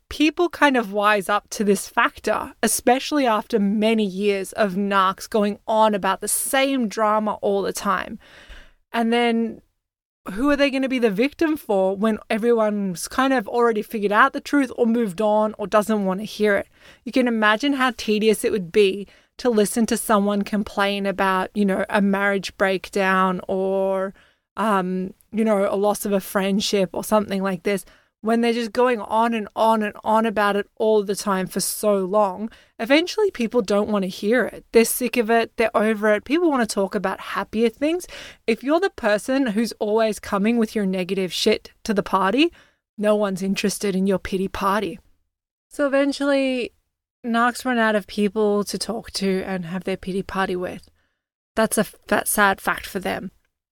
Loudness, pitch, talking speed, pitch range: -21 LUFS, 215 Hz, 185 wpm, 200-235 Hz